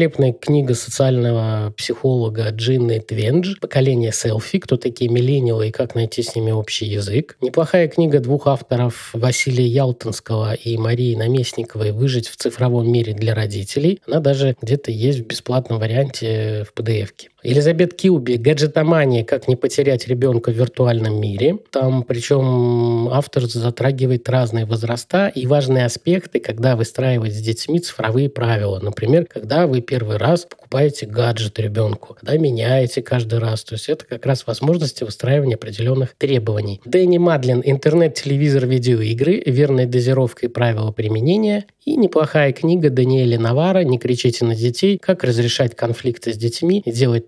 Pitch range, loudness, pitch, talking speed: 115-140 Hz, -18 LUFS, 125 Hz, 145 wpm